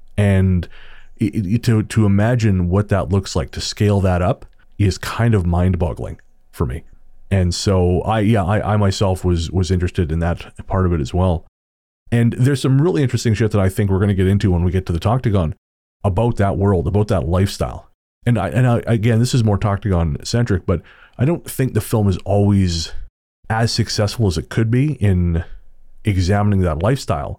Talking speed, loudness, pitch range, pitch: 190 wpm, -18 LUFS, 90-110 Hz, 100 Hz